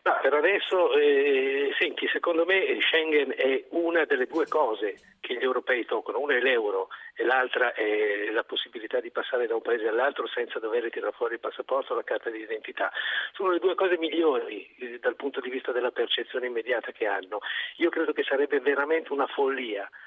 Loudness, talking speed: -27 LUFS, 190 wpm